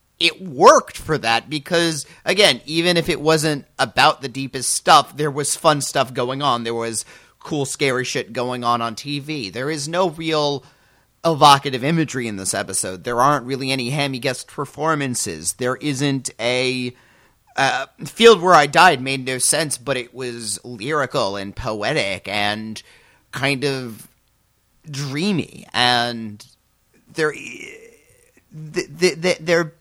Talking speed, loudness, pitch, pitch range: 140 wpm, -19 LUFS, 140 Hz, 120-155 Hz